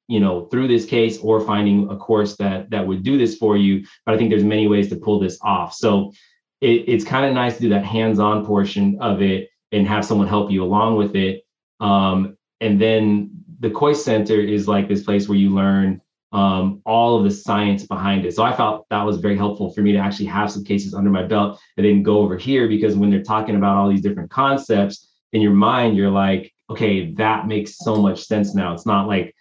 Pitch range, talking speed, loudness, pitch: 100-110 Hz, 230 wpm, -18 LUFS, 105 Hz